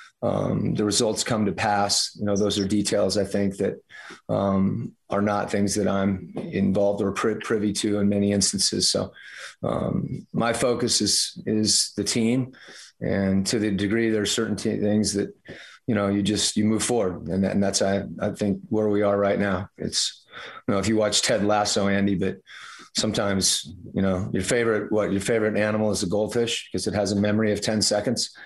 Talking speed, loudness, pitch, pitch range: 200 wpm, -23 LUFS, 105 Hz, 100-105 Hz